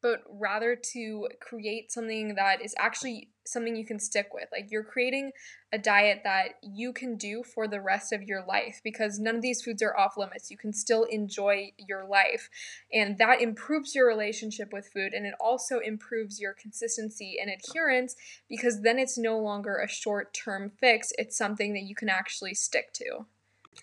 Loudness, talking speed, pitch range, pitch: -29 LUFS, 185 wpm, 205-240 Hz, 220 Hz